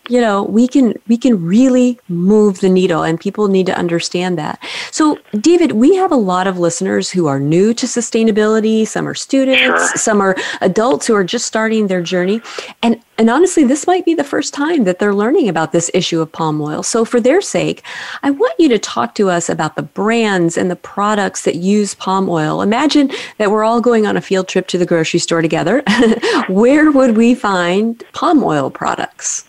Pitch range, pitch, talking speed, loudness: 185-245 Hz, 210 Hz, 205 wpm, -14 LUFS